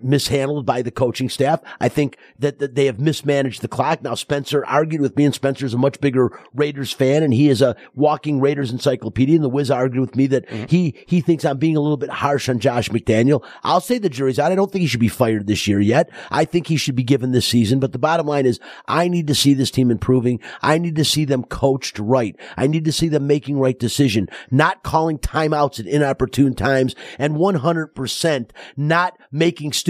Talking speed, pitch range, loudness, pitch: 225 wpm, 130-150 Hz, -19 LUFS, 140 Hz